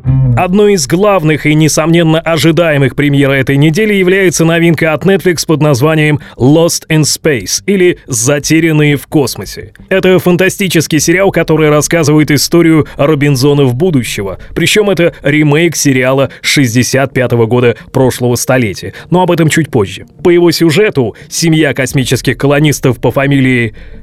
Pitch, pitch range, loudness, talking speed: 150 Hz, 130-170 Hz, -9 LUFS, 125 wpm